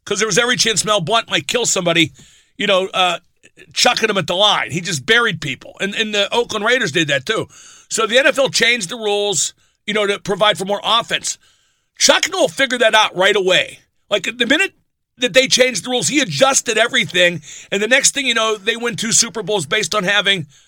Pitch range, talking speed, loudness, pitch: 190-235 Hz, 220 wpm, -15 LUFS, 215 Hz